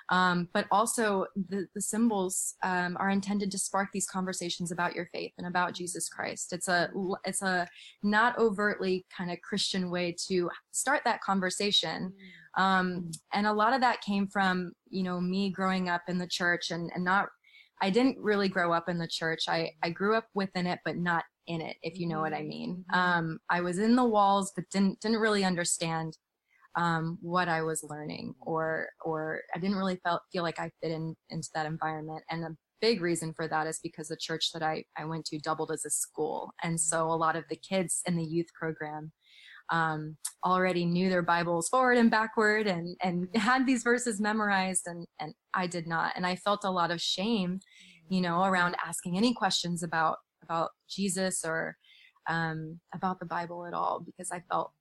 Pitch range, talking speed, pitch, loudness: 165-195 Hz, 200 wpm, 180 Hz, -30 LUFS